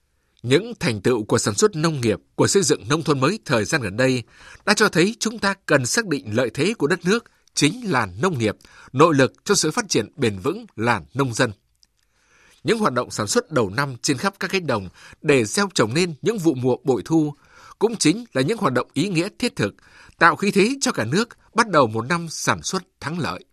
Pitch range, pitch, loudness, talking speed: 130-195 Hz, 160 Hz, -21 LUFS, 230 wpm